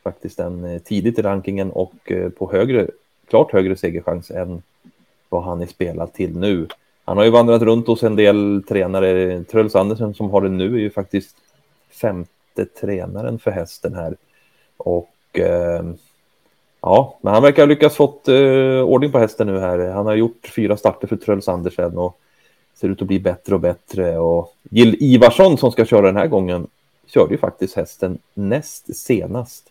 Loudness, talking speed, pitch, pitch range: -17 LUFS, 170 wpm, 100 Hz, 90-115 Hz